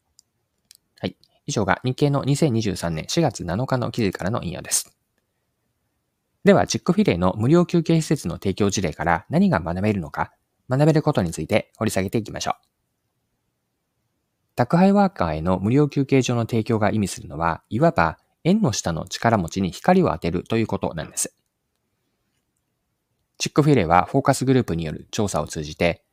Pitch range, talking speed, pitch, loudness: 90-145 Hz, 335 characters per minute, 110 Hz, -21 LUFS